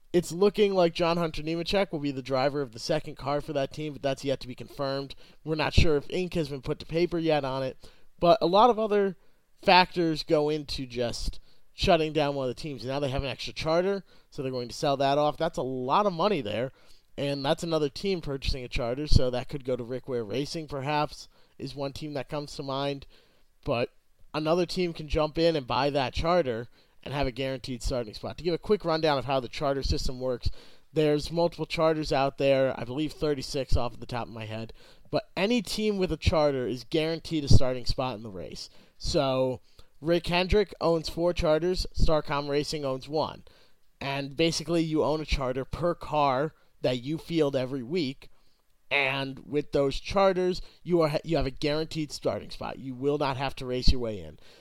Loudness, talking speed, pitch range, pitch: -28 LUFS, 210 wpm, 130-165 Hz, 145 Hz